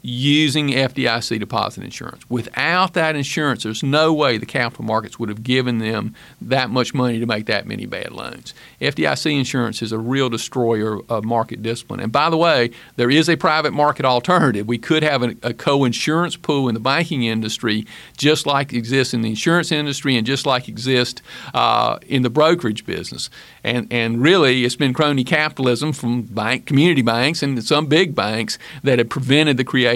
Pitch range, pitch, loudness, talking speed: 115-150 Hz, 130 Hz, -18 LUFS, 185 wpm